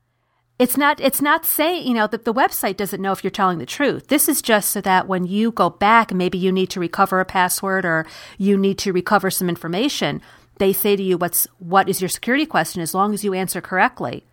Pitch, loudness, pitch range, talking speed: 195 Hz, -19 LUFS, 185-225 Hz, 235 wpm